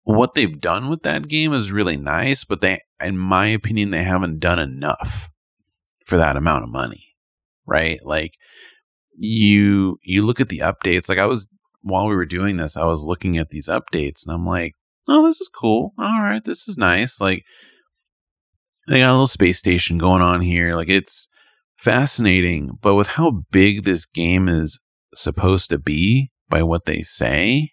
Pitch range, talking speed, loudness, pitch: 85-110 Hz, 180 wpm, -18 LUFS, 95 Hz